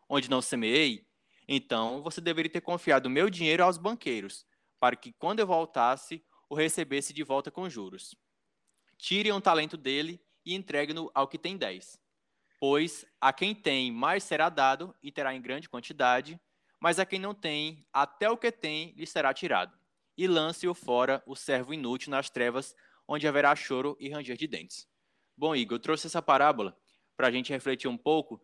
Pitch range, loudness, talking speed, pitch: 135-170 Hz, -30 LUFS, 180 wpm, 150 Hz